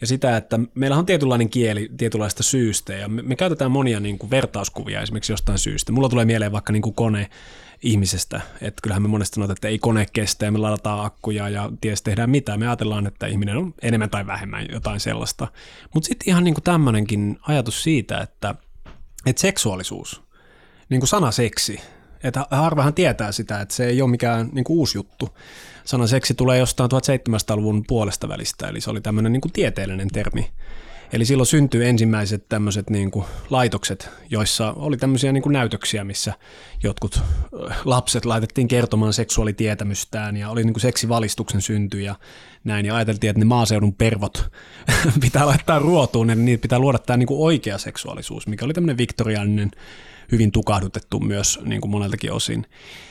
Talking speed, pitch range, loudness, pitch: 170 wpm, 105-130 Hz, -21 LUFS, 115 Hz